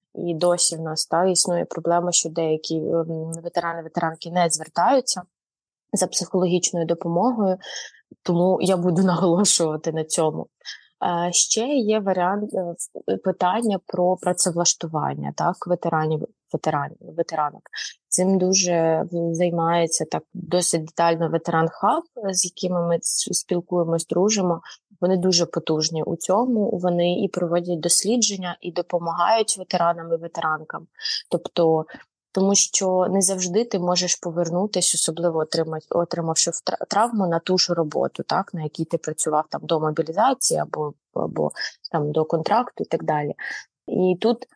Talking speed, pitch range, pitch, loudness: 120 wpm, 165-185 Hz, 175 Hz, -22 LUFS